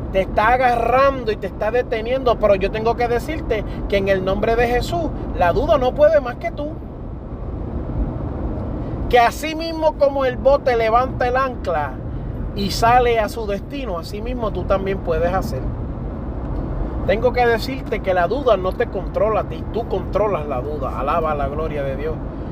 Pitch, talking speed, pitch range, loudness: 240 Hz, 170 wpm, 225-265 Hz, -20 LUFS